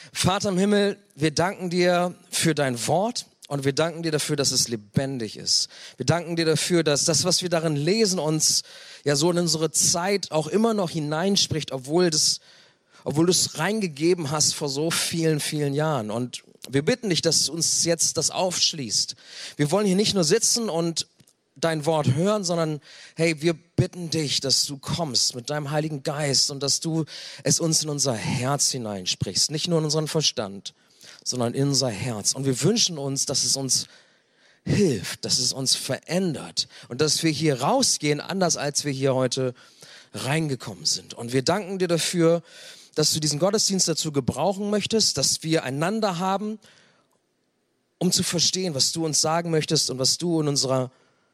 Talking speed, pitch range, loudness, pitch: 180 wpm, 140-175 Hz, -23 LUFS, 155 Hz